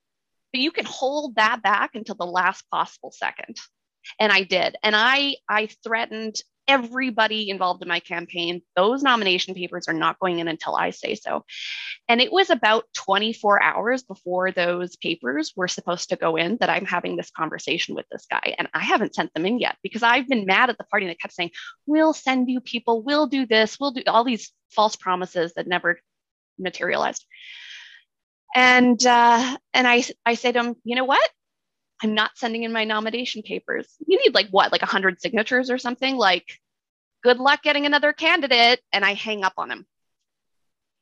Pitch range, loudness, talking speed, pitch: 190-255 Hz, -21 LUFS, 185 wpm, 225 Hz